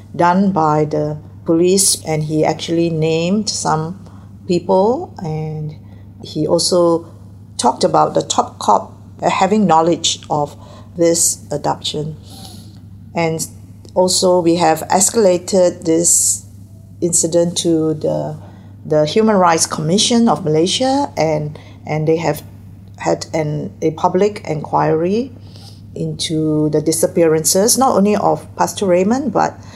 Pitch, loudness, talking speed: 155 Hz, -15 LUFS, 115 wpm